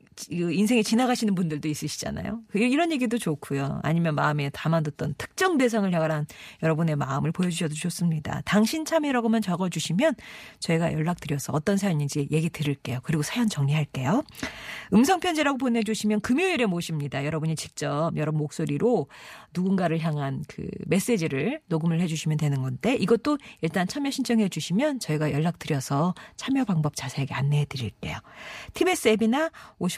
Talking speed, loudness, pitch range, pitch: 390 characters per minute, -26 LUFS, 150-225 Hz, 170 Hz